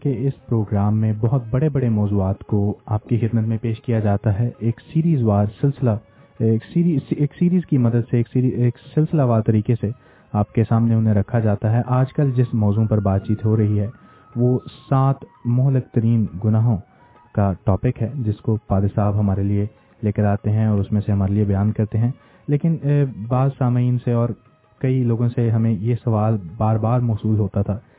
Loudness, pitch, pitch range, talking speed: -20 LUFS, 115 Hz, 105-125 Hz, 205 wpm